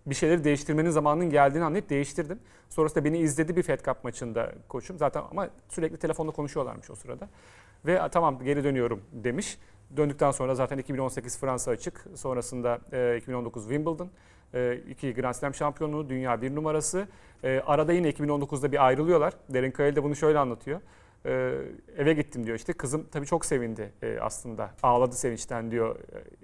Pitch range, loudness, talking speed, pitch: 125-155 Hz, -28 LUFS, 160 wpm, 140 Hz